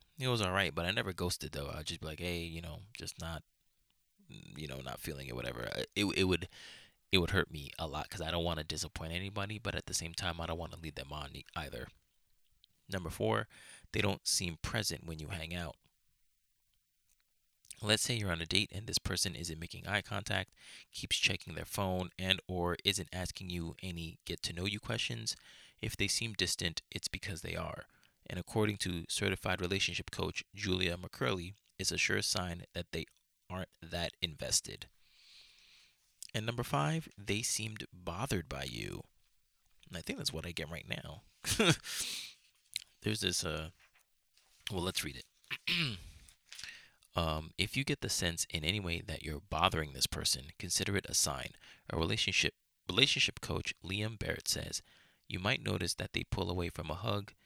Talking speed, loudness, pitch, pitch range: 180 wpm, -36 LUFS, 90 Hz, 80-100 Hz